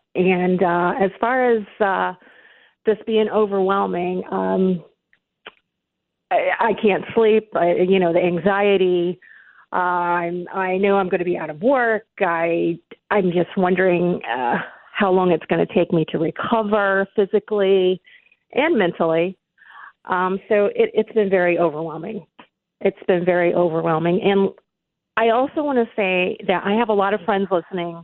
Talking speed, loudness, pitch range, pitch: 150 wpm, -19 LUFS, 175-210 Hz, 185 Hz